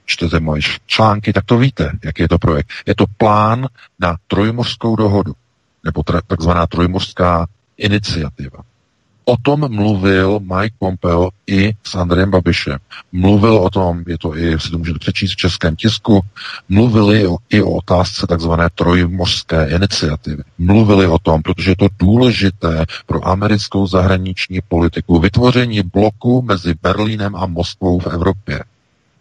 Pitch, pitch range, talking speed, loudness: 95 Hz, 85-105 Hz, 140 wpm, -14 LUFS